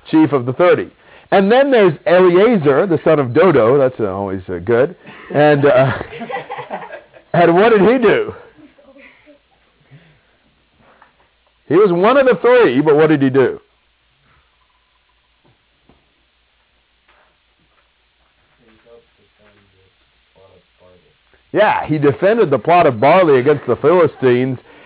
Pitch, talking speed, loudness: 135 Hz, 110 wpm, -13 LUFS